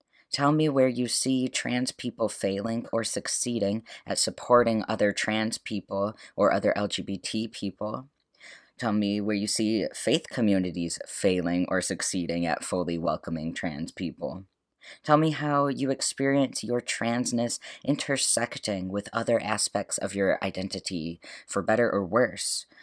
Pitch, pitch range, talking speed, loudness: 105 Hz, 95-125 Hz, 135 wpm, -27 LUFS